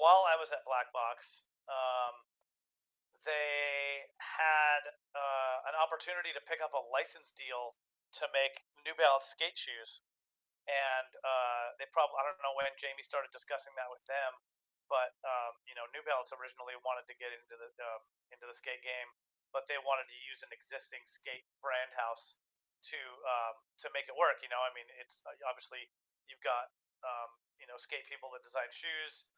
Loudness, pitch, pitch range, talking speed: -37 LUFS, 130 Hz, 120-140 Hz, 175 wpm